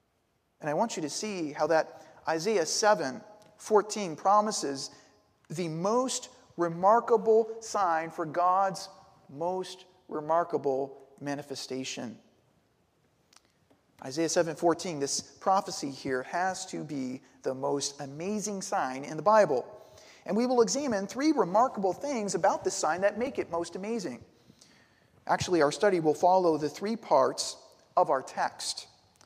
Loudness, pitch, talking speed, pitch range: -29 LUFS, 180 Hz, 125 wpm, 150-205 Hz